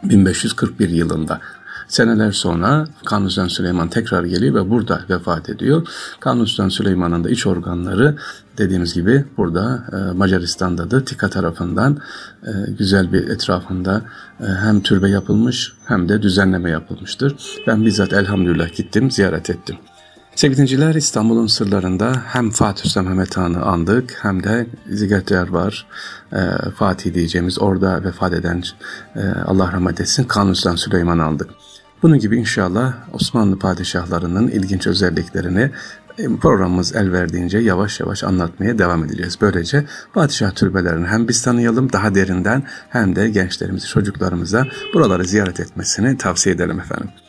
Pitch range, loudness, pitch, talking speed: 90-115 Hz, -17 LUFS, 100 Hz, 125 wpm